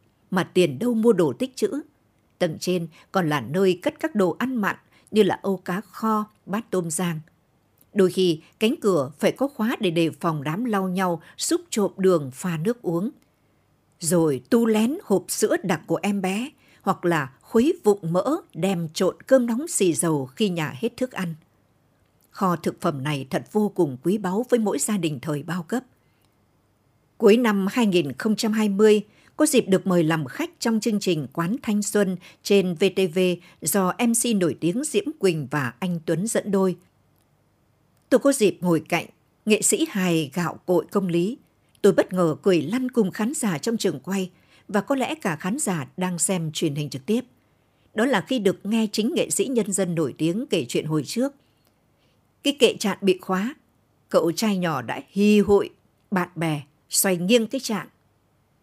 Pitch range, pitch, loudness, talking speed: 170-220 Hz, 190 Hz, -23 LUFS, 185 wpm